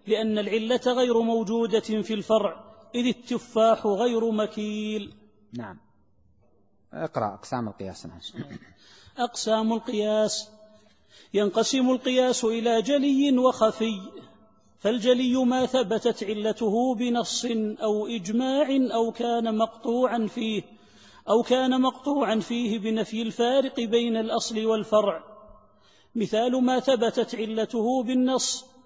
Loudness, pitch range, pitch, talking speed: -25 LUFS, 215-245 Hz, 225 Hz, 95 wpm